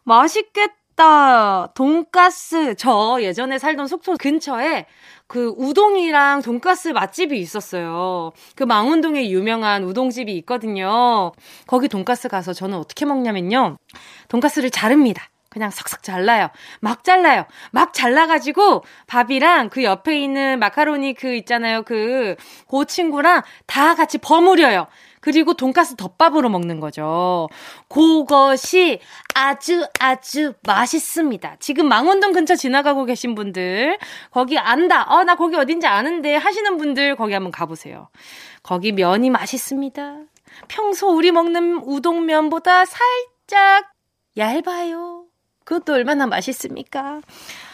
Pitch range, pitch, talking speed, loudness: 235-335 Hz, 280 Hz, 280 characters per minute, -17 LUFS